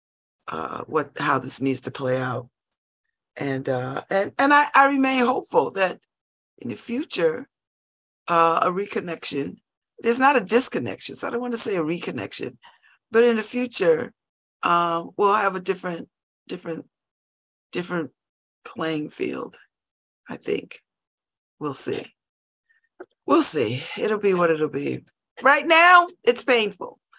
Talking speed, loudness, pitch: 140 wpm, -22 LUFS, 205 Hz